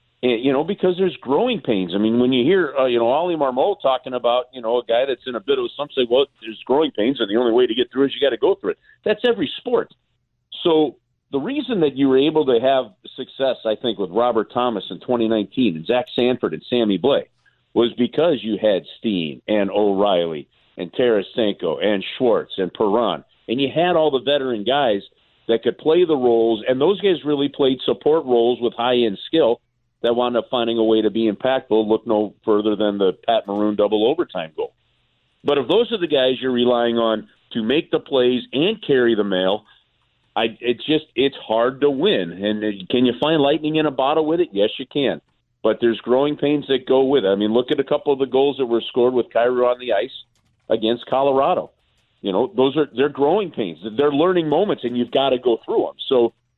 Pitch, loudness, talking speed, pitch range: 125 Hz, -19 LUFS, 225 wpm, 115-145 Hz